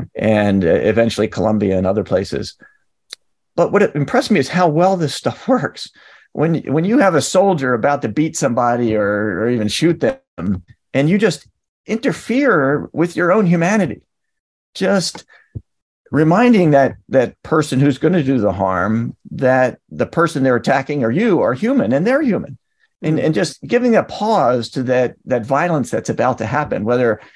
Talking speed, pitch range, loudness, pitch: 170 wpm, 115-190 Hz, -16 LUFS, 145 Hz